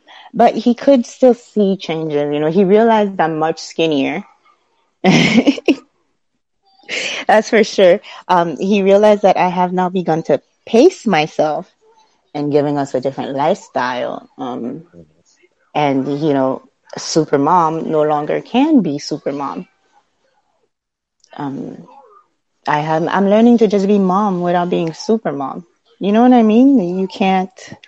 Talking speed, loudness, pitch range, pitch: 135 wpm, -15 LUFS, 160-240 Hz, 195 Hz